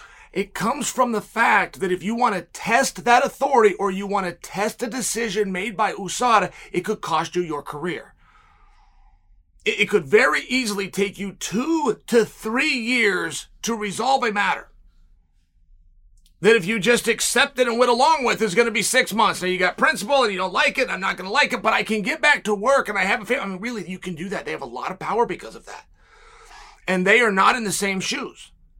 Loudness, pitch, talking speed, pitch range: -21 LUFS, 215 Hz, 235 wpm, 185-245 Hz